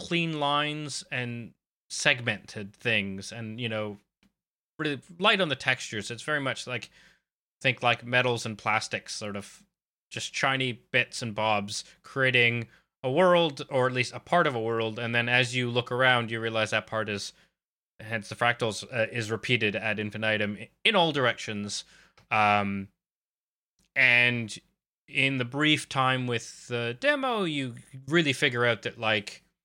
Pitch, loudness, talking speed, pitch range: 120 Hz, -27 LUFS, 155 wpm, 110-135 Hz